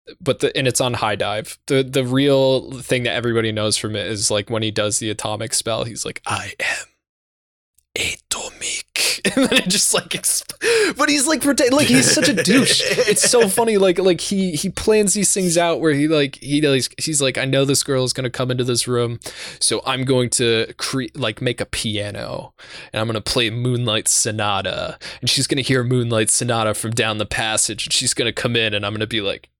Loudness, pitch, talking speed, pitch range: -18 LUFS, 125 Hz, 215 wpm, 110-155 Hz